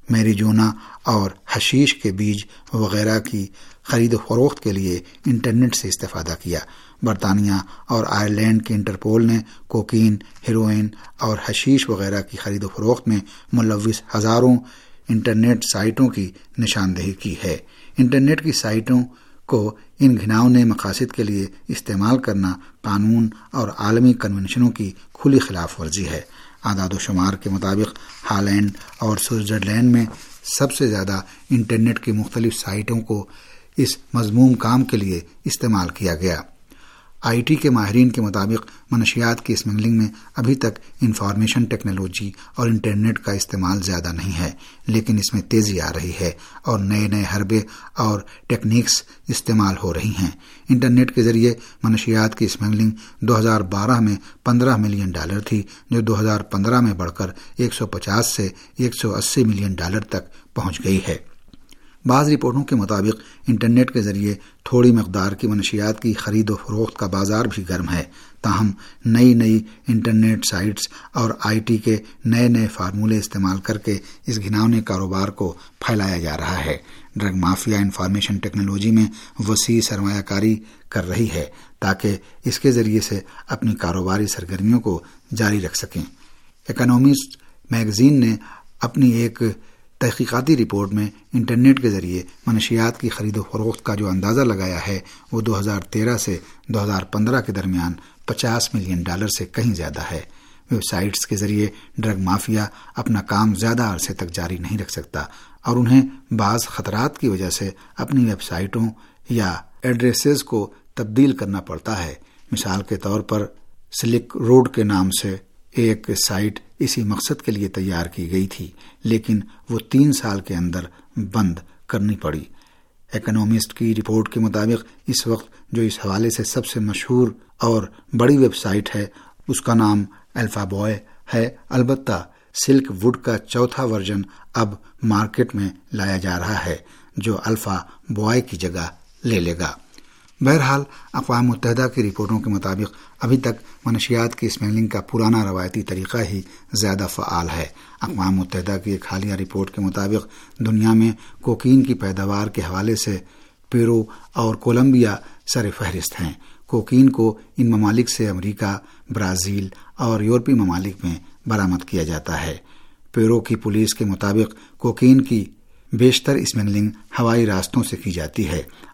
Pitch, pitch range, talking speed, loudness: 110 Hz, 100-115 Hz, 155 wpm, -20 LUFS